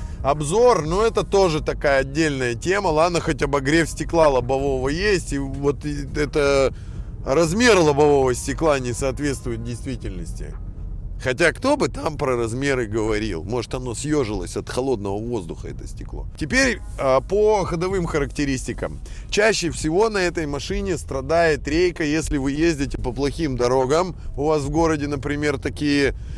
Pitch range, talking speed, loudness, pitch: 130-165 Hz, 135 wpm, -21 LUFS, 145 Hz